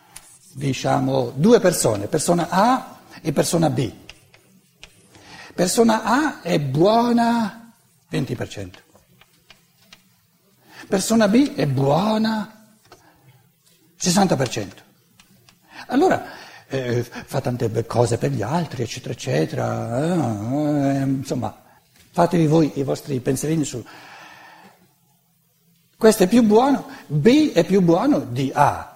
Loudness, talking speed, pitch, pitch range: -20 LUFS, 95 wpm, 160 Hz, 135-215 Hz